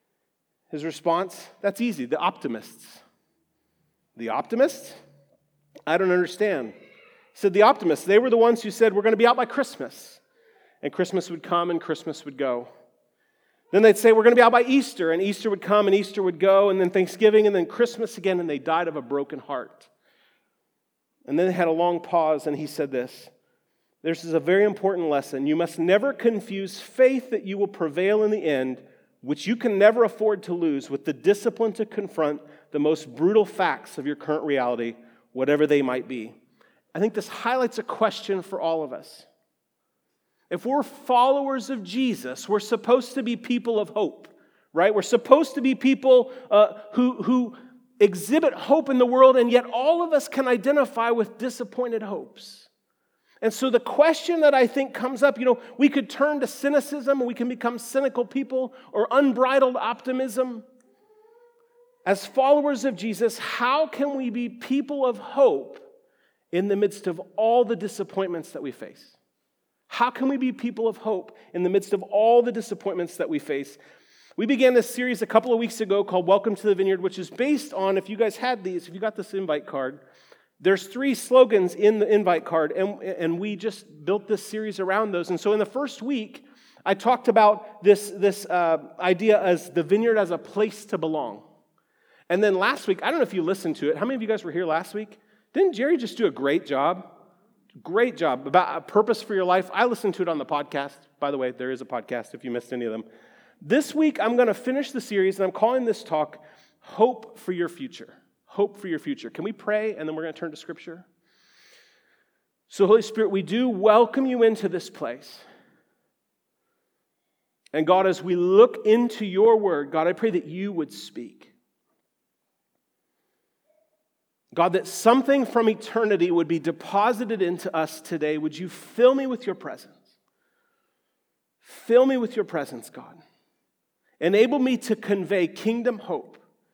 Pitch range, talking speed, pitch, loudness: 175-250 Hz, 195 wpm, 210 Hz, -23 LUFS